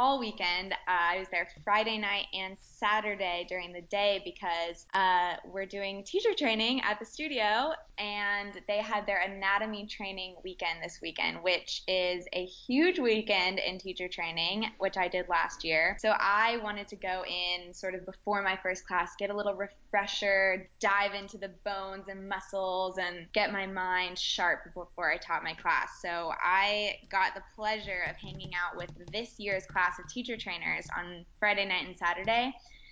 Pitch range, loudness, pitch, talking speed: 180-210 Hz, -31 LUFS, 195 Hz, 175 wpm